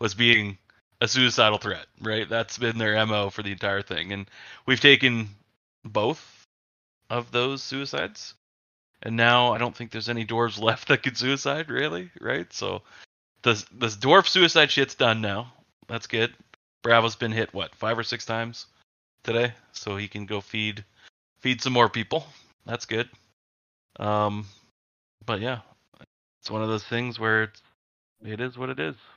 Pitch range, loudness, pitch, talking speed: 105-120 Hz, -24 LUFS, 115 Hz, 165 wpm